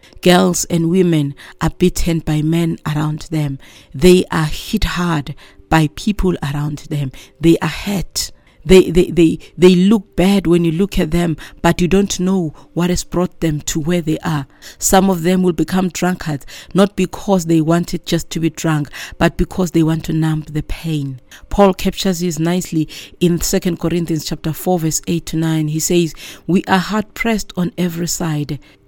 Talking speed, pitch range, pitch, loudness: 180 wpm, 155-180 Hz, 170 Hz, -16 LUFS